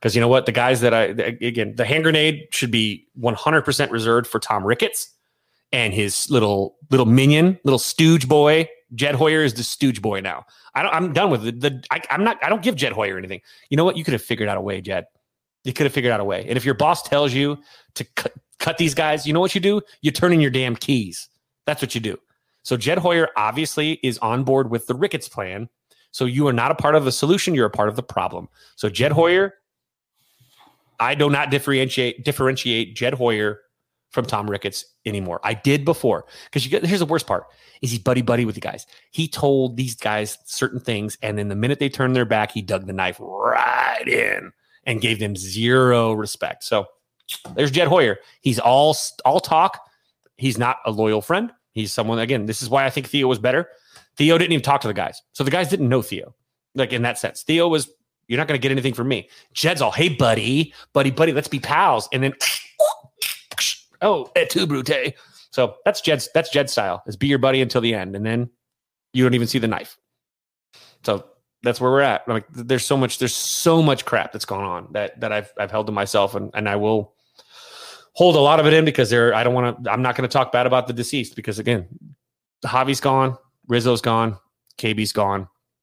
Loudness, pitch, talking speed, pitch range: -20 LUFS, 130 Hz, 225 wpm, 115-145 Hz